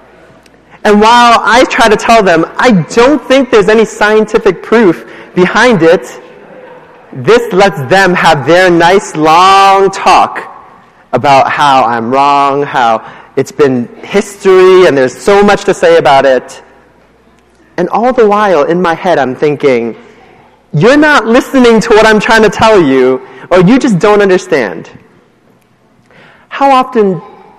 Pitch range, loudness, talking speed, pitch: 165-235 Hz, -7 LUFS, 145 wpm, 200 Hz